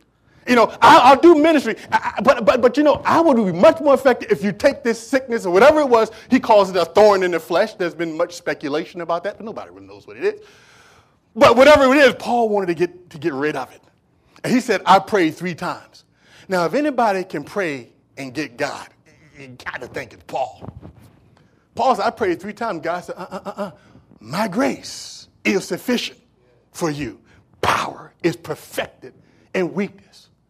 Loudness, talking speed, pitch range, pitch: -17 LUFS, 200 wpm, 170-250 Hz, 200 Hz